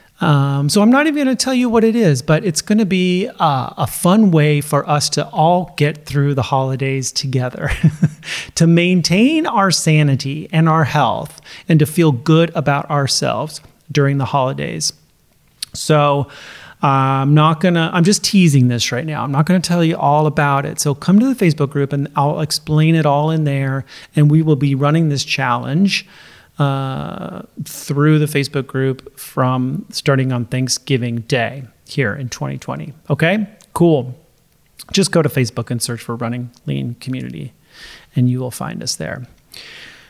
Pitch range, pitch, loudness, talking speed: 135-165 Hz, 150 Hz, -16 LUFS, 175 wpm